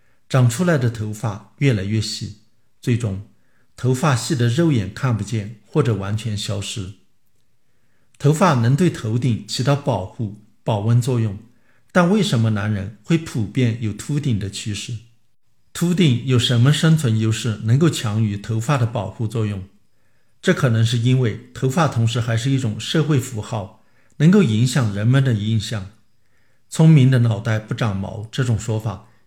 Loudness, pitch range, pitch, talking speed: -20 LUFS, 110-130 Hz, 115 Hz, 235 characters per minute